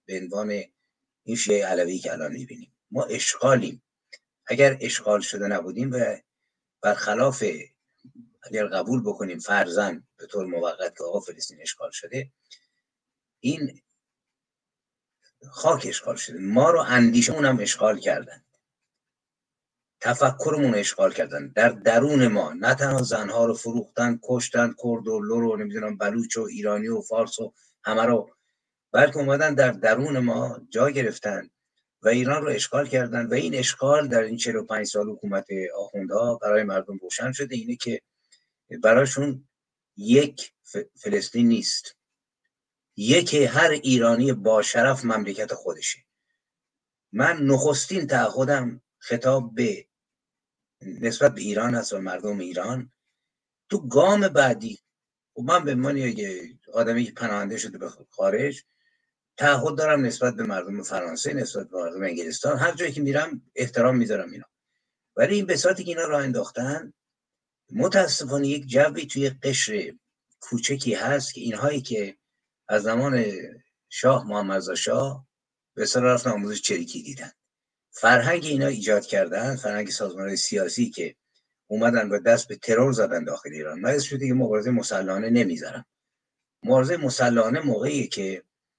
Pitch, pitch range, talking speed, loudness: 130 Hz, 115-145 Hz, 135 wpm, -24 LUFS